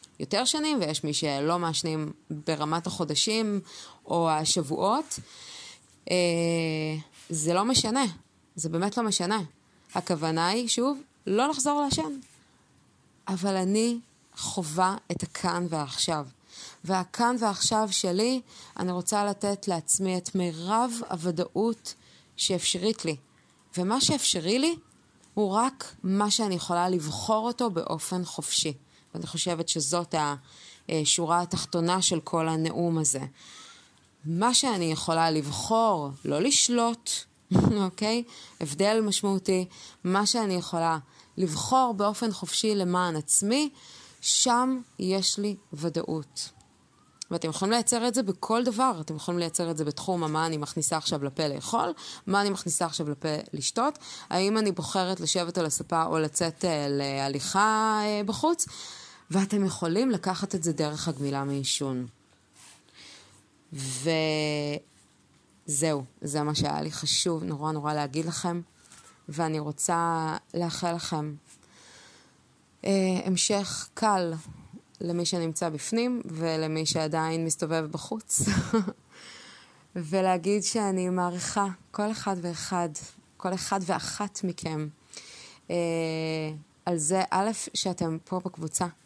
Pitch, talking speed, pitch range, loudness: 175 Hz, 115 wpm, 160-205 Hz, -27 LUFS